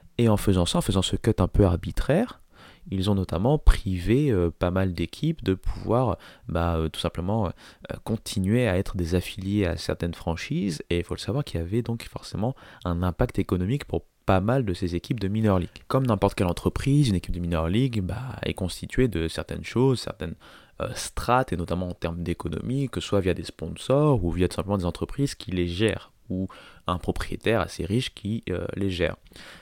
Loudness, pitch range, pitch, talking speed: -26 LUFS, 85-115 Hz, 95 Hz, 210 wpm